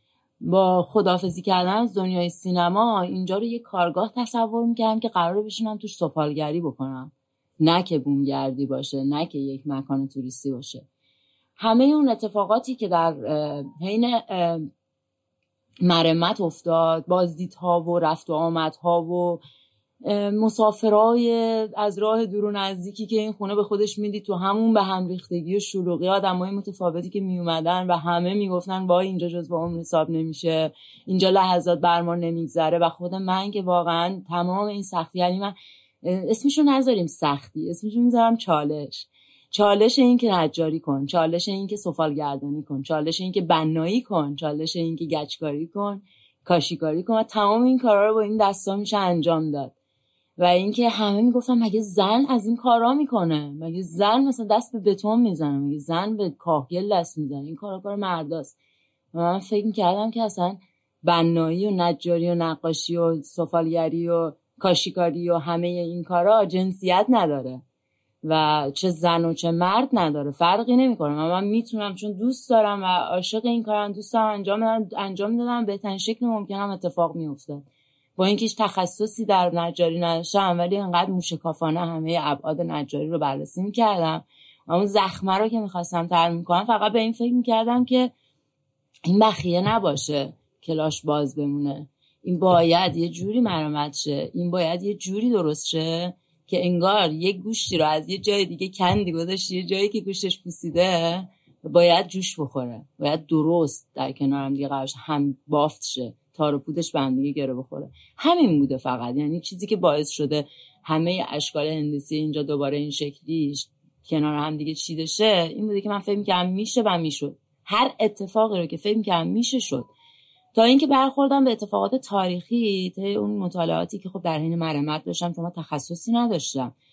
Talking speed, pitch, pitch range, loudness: 160 wpm, 175 Hz, 155-205 Hz, -23 LUFS